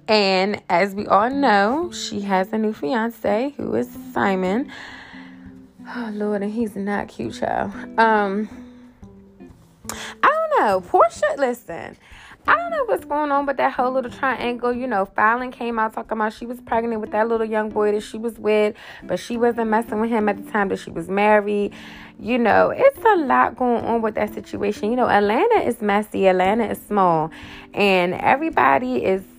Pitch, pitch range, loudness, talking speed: 220 Hz, 200-245 Hz, -20 LUFS, 185 wpm